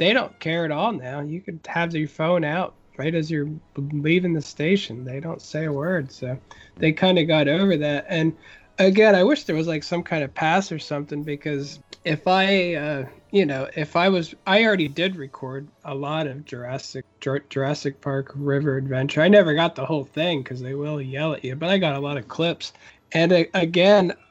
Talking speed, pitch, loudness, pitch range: 215 wpm, 155 Hz, -22 LUFS, 140-175 Hz